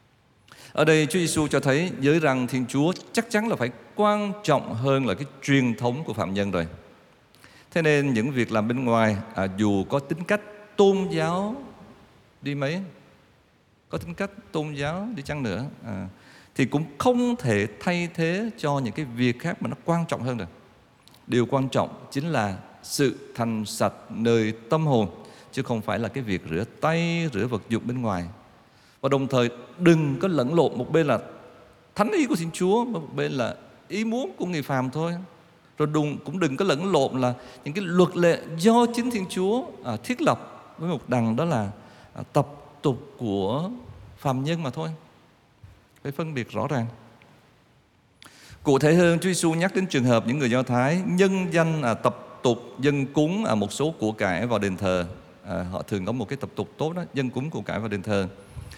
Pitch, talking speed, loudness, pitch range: 135 Hz, 200 wpm, -25 LUFS, 115-170 Hz